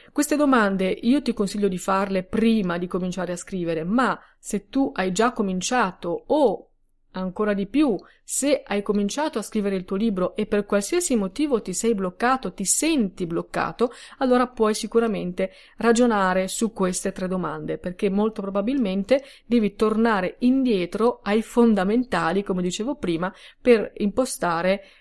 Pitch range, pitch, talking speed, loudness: 185-235 Hz, 205 Hz, 145 wpm, -23 LUFS